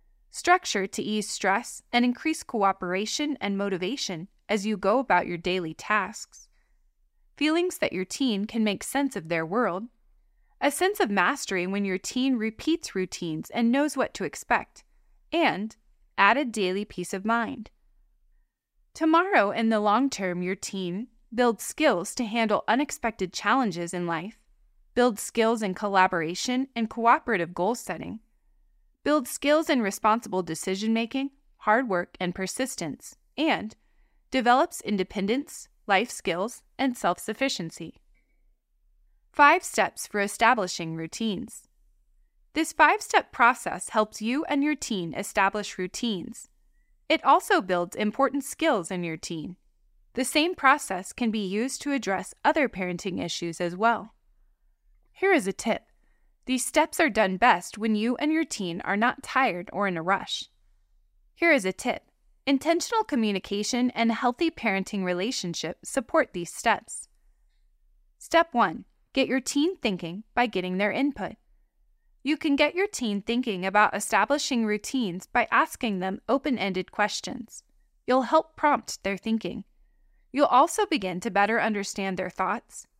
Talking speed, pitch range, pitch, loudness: 140 wpm, 190-275 Hz, 225 Hz, -26 LUFS